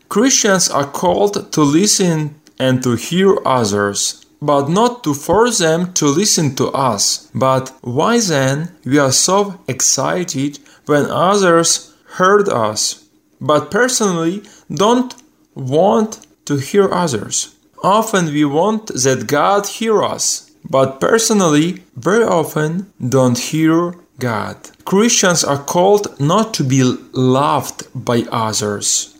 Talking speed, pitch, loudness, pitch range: 120 wpm, 155 Hz, -15 LUFS, 130-195 Hz